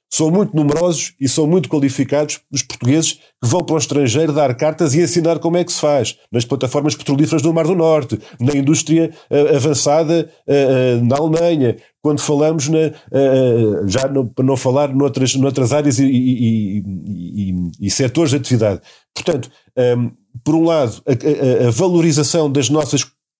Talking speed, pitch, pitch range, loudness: 170 wpm, 145 Hz, 130-155 Hz, -16 LUFS